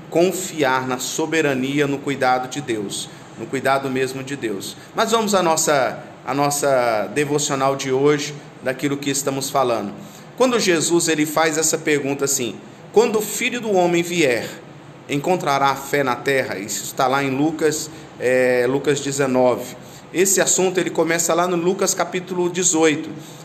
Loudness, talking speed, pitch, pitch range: -19 LUFS, 155 wpm, 150 Hz, 135-170 Hz